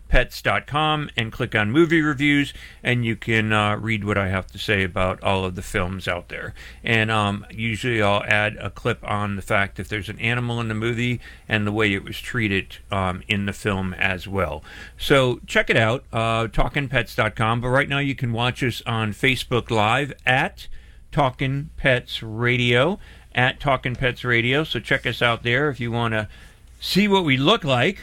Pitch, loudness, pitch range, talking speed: 115 Hz, -22 LUFS, 105-125 Hz, 195 wpm